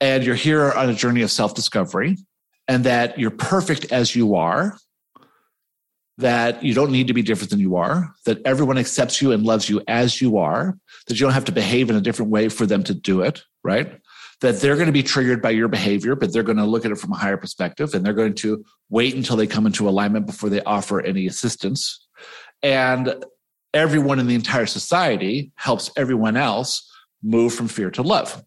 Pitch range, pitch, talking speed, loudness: 110-135 Hz, 120 Hz, 215 wpm, -20 LUFS